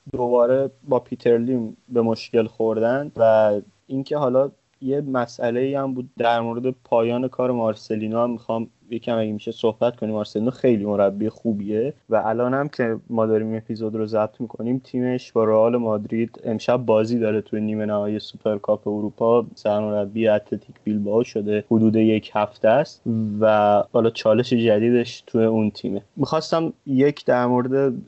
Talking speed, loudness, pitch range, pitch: 155 wpm, -21 LUFS, 110-125 Hz, 115 Hz